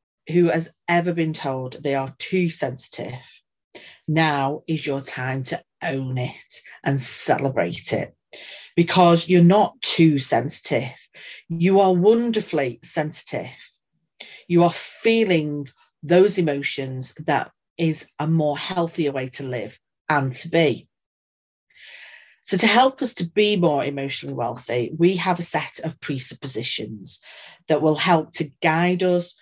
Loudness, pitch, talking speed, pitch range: -21 LUFS, 160 Hz, 135 wpm, 135-175 Hz